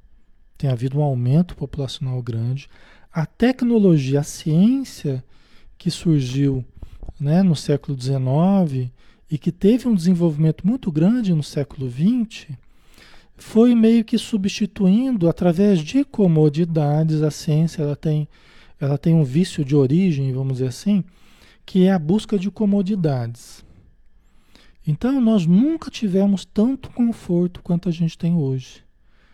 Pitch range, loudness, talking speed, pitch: 140-200 Hz, -20 LUFS, 130 wpm, 165 Hz